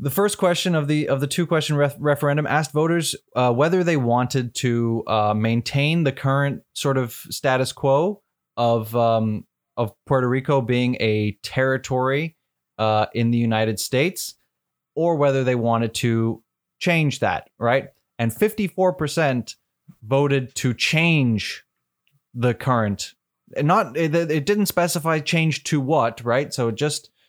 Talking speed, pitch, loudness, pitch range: 150 wpm, 135 Hz, -21 LUFS, 115-155 Hz